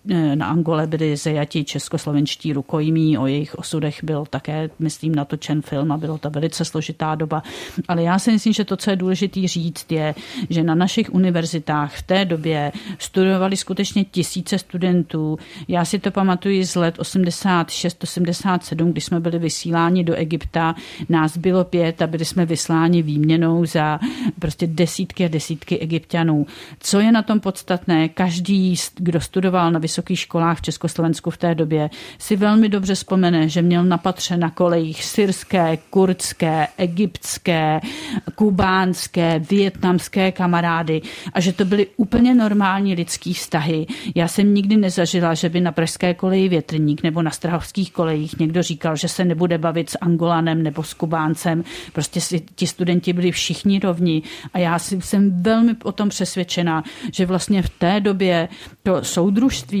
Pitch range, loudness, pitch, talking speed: 160-190 Hz, -19 LUFS, 170 Hz, 155 wpm